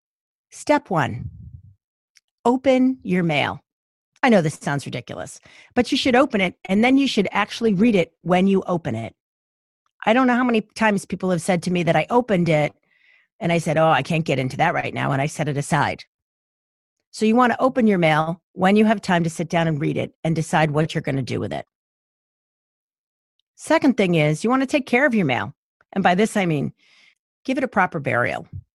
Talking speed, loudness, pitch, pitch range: 215 wpm, -20 LUFS, 180 Hz, 155-235 Hz